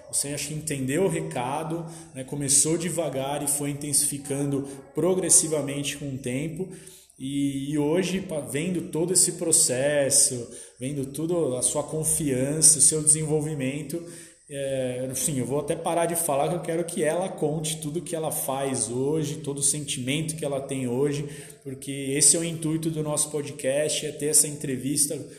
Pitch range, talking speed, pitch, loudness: 140-160 Hz, 160 wpm, 145 Hz, -24 LUFS